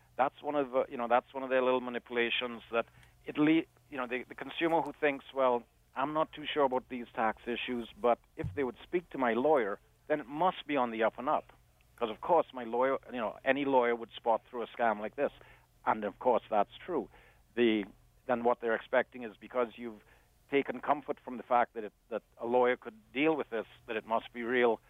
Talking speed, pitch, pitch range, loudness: 230 wpm, 125 Hz, 115-140 Hz, -33 LUFS